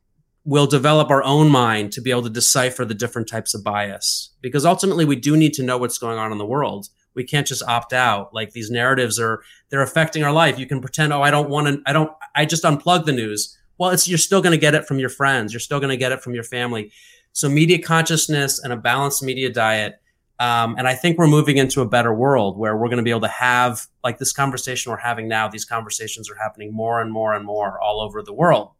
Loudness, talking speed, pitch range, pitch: -19 LUFS, 245 wpm, 115-145 Hz, 125 Hz